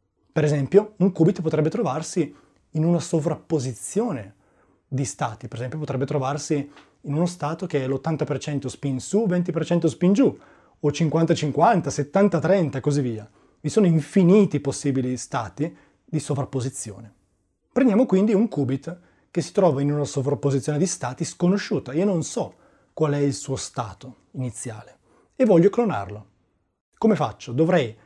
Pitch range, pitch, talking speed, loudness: 130-175 Hz, 150 Hz, 145 wpm, -23 LUFS